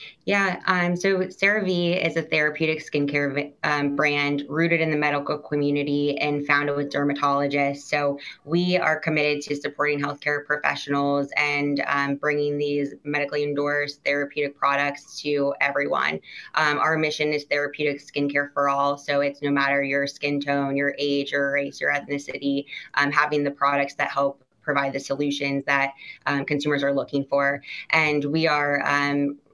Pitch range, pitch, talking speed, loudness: 140-150 Hz, 145 Hz, 160 wpm, -23 LUFS